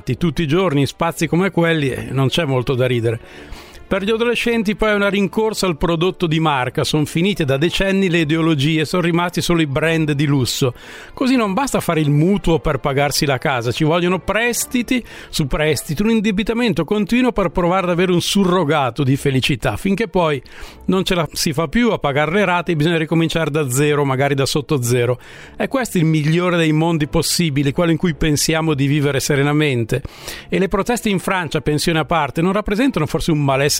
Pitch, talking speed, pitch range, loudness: 165 Hz, 195 wpm, 145-190 Hz, -17 LUFS